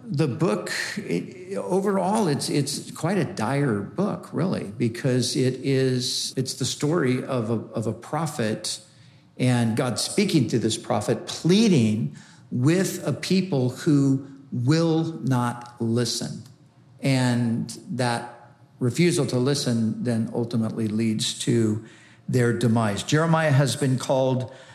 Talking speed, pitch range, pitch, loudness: 125 wpm, 120-145 Hz, 125 Hz, -24 LUFS